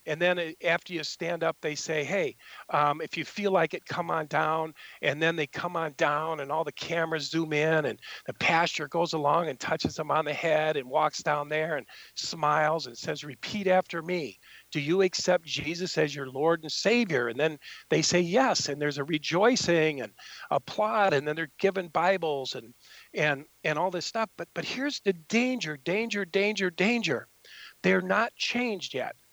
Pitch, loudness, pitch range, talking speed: 165 Hz, -28 LUFS, 150-185 Hz, 195 wpm